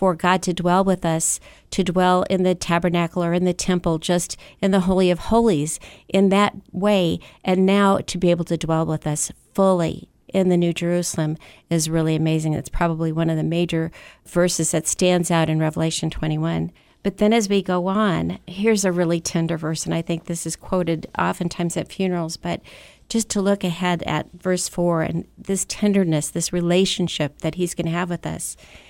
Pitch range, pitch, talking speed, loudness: 165-185 Hz, 175 Hz, 195 wpm, -21 LUFS